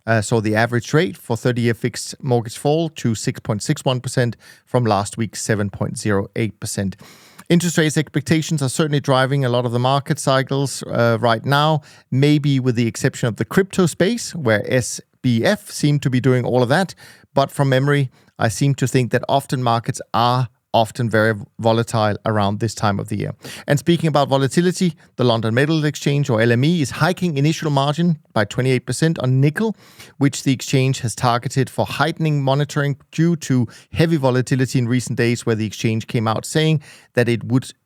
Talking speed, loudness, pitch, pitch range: 175 wpm, -19 LUFS, 130 Hz, 115-145 Hz